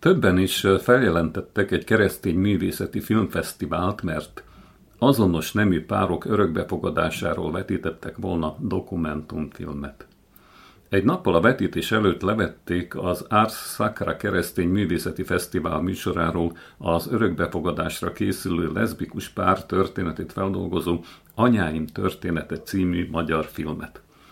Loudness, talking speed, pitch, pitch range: -24 LUFS, 100 wpm, 90 Hz, 85-95 Hz